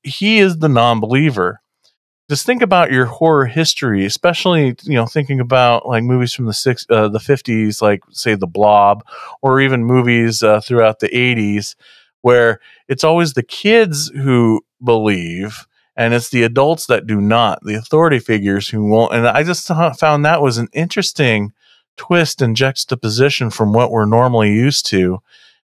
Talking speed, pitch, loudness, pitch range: 165 wpm, 120 Hz, -14 LUFS, 110-145 Hz